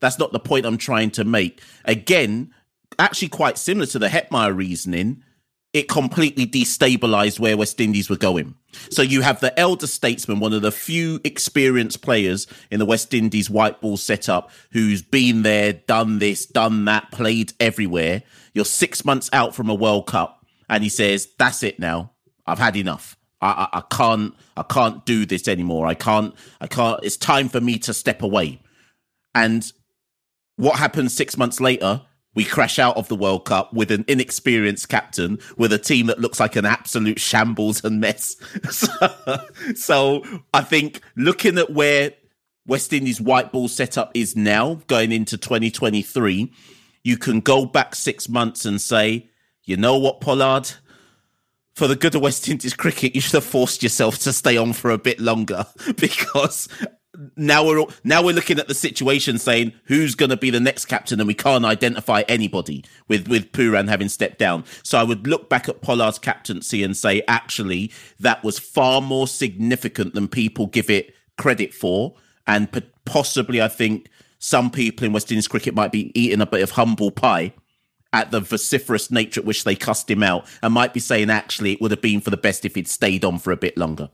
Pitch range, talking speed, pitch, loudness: 105-130 Hz, 190 wpm, 115 Hz, -19 LUFS